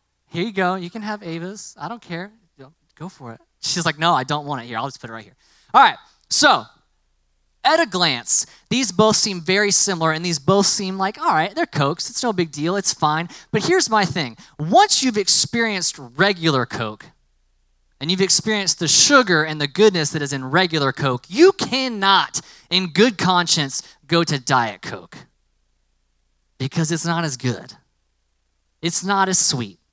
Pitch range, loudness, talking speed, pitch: 130-195 Hz, -18 LUFS, 185 wpm, 165 Hz